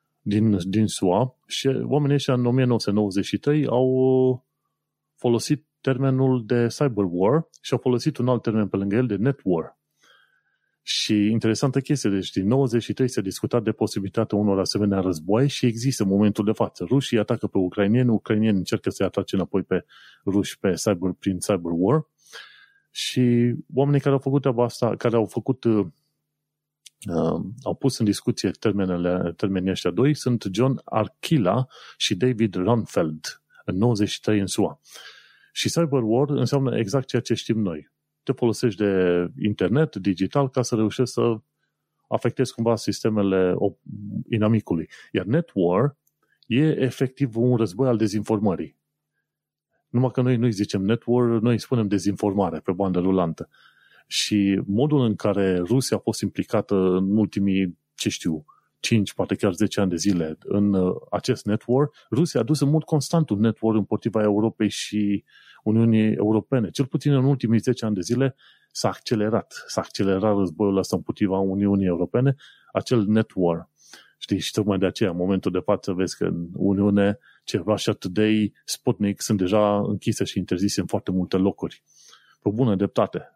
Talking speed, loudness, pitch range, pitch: 155 wpm, -23 LUFS, 100-130 Hz, 110 Hz